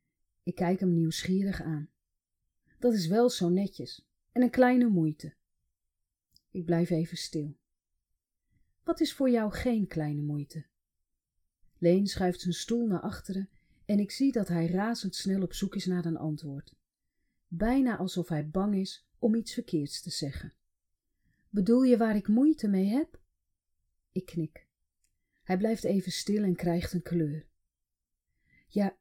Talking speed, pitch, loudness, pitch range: 145 wpm, 185 Hz, -30 LUFS, 160-215 Hz